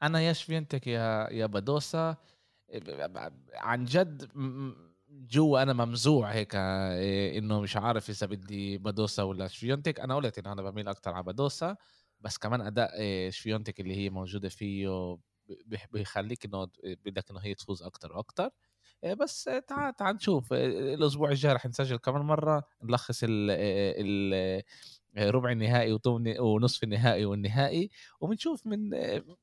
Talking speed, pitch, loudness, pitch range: 135 wpm, 115 Hz, -31 LUFS, 100-140 Hz